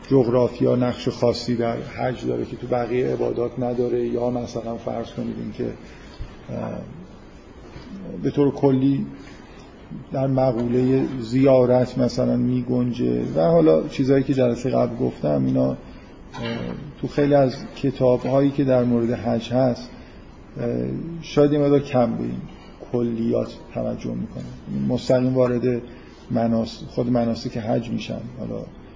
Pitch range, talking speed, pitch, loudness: 115-130 Hz, 125 wpm, 120 Hz, -22 LUFS